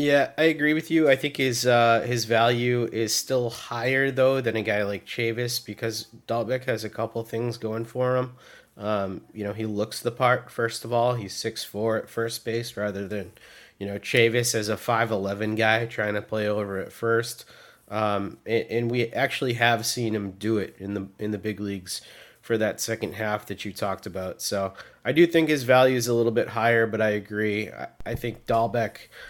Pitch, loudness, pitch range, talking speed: 115 Hz, -25 LUFS, 105-120 Hz, 210 wpm